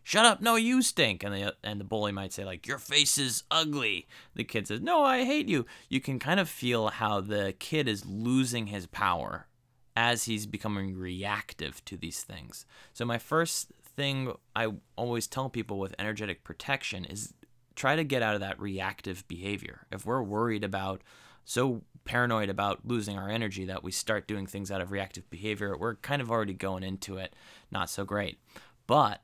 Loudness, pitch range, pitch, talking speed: -31 LUFS, 100-125 Hz, 105 Hz, 190 wpm